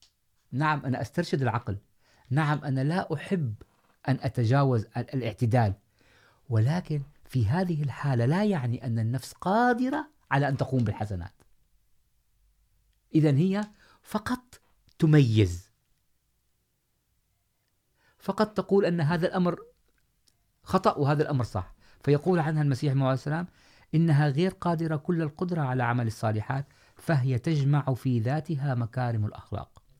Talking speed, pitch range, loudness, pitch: 110 wpm, 115-160 Hz, -27 LUFS, 135 Hz